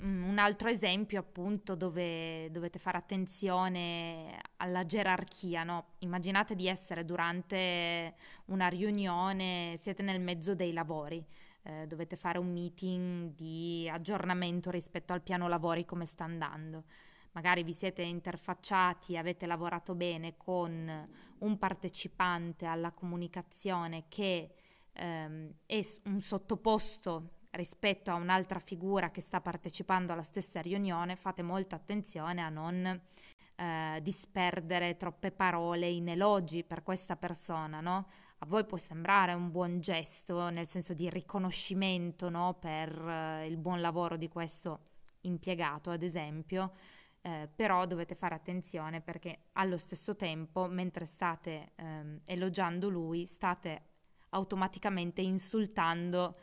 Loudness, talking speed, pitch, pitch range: -36 LUFS, 125 wpm, 180 Hz, 170-185 Hz